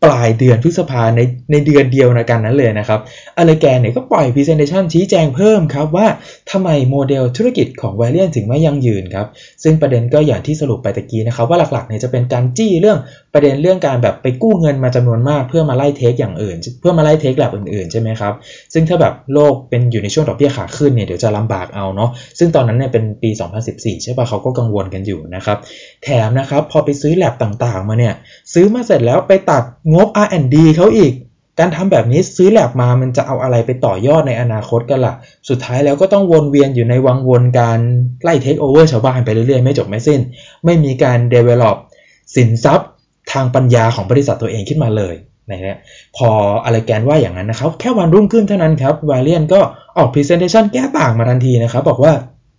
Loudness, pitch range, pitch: -13 LUFS, 115-155 Hz, 130 Hz